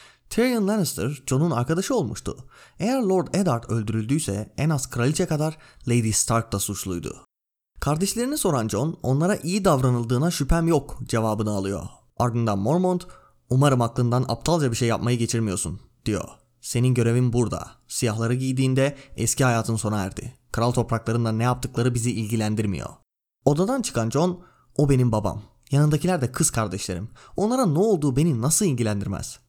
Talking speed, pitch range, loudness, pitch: 140 wpm, 115-155 Hz, -24 LUFS, 125 Hz